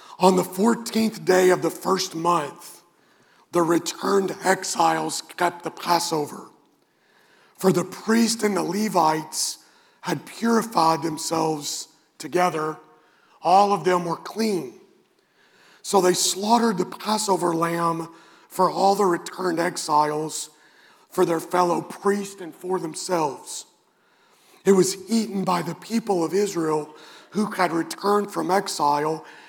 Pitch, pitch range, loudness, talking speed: 180 Hz, 165-200 Hz, -23 LUFS, 120 wpm